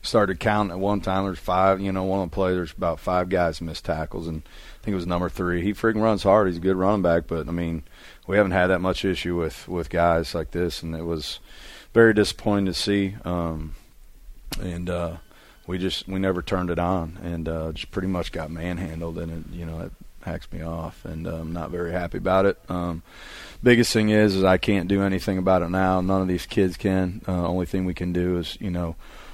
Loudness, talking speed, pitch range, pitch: -24 LUFS, 235 wpm, 85-95 Hz, 90 Hz